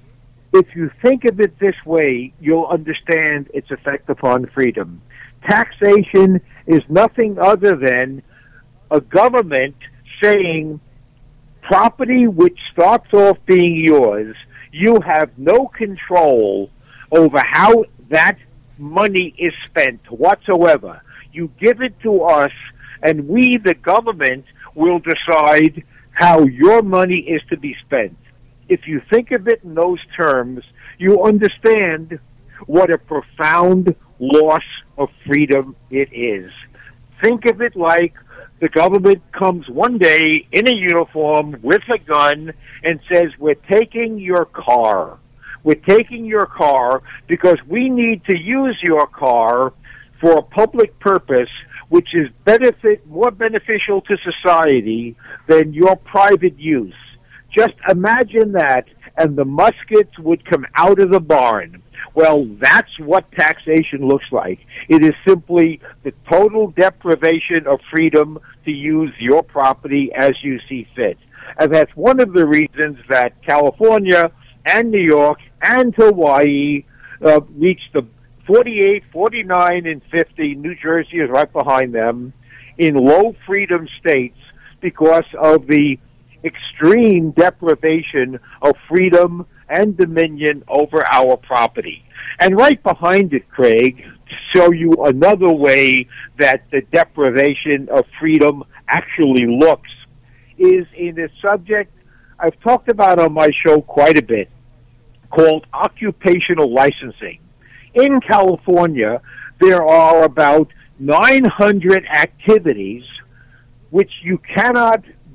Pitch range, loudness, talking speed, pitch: 140-190 Hz, -14 LUFS, 125 wpm, 160 Hz